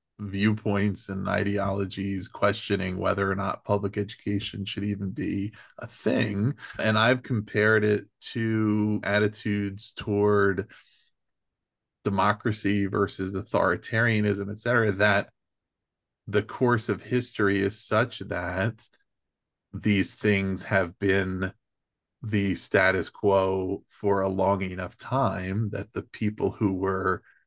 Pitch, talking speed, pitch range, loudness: 100 Hz, 110 wpm, 95-105 Hz, -26 LUFS